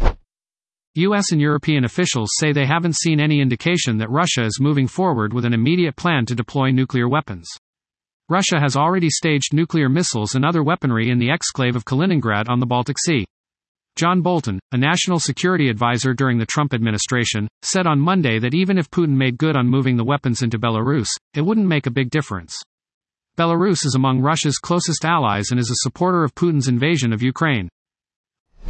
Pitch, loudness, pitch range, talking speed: 140 Hz, -18 LUFS, 125-165 Hz, 180 wpm